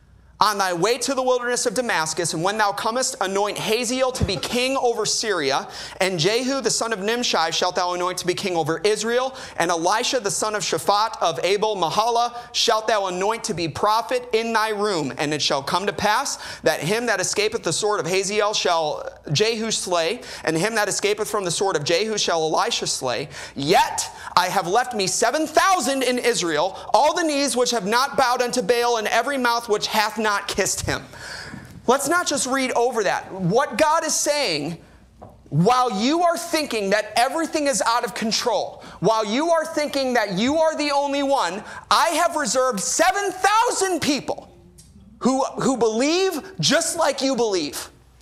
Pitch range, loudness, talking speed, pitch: 195-270 Hz, -21 LUFS, 185 wpm, 230 Hz